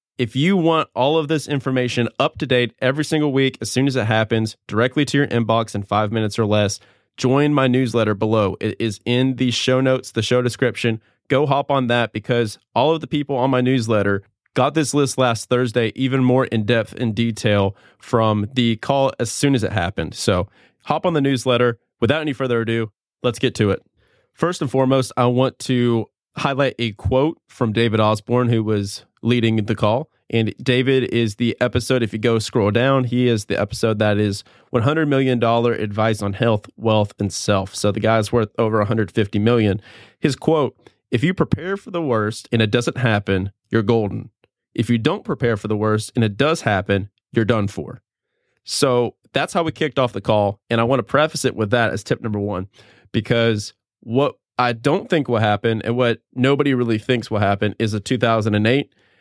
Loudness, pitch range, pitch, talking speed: -19 LUFS, 110-130 Hz, 120 Hz, 200 wpm